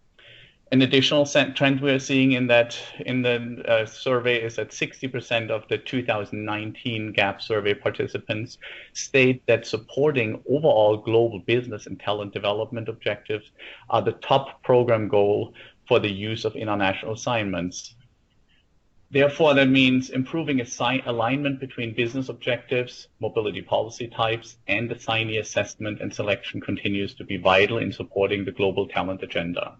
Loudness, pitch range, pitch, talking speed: -23 LUFS, 105-130 Hz, 115 Hz, 140 wpm